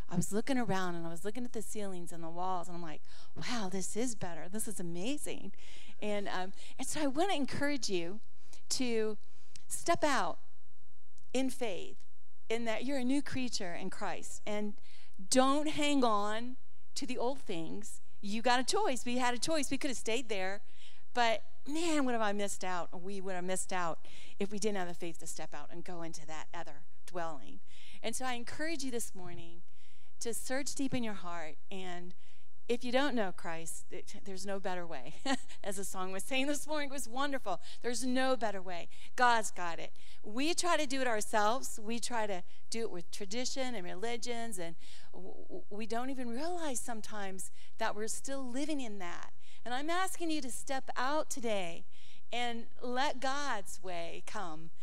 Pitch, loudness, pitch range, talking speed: 220 Hz, -37 LUFS, 180-260 Hz, 190 wpm